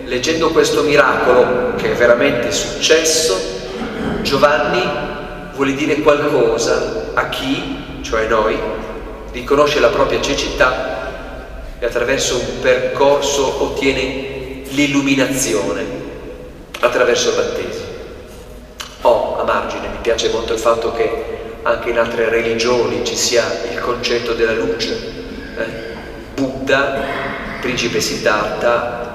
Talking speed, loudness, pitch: 105 wpm, -16 LUFS, 140 Hz